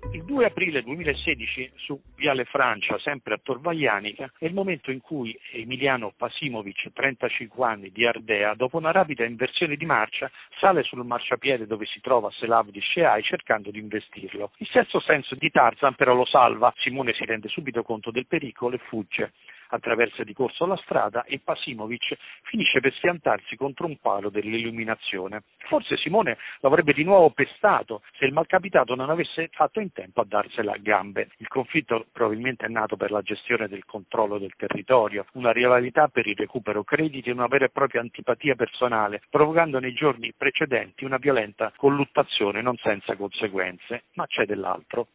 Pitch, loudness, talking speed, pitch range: 125 Hz, -24 LUFS, 165 wpm, 110-140 Hz